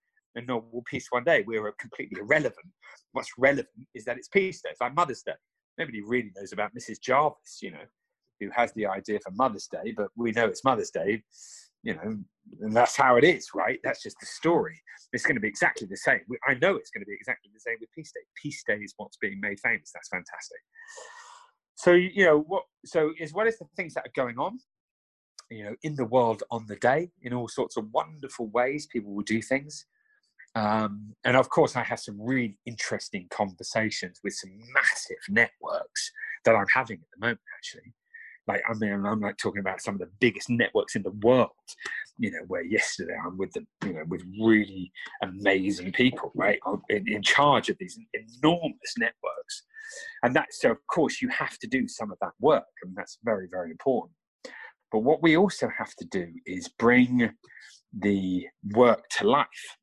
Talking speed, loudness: 200 wpm, -27 LUFS